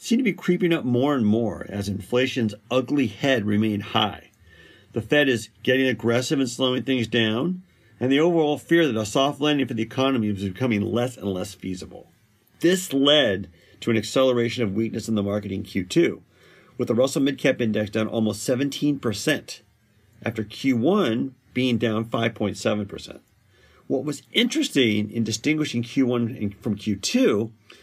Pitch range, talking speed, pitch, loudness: 105-135 Hz, 160 wpm, 115 Hz, -23 LUFS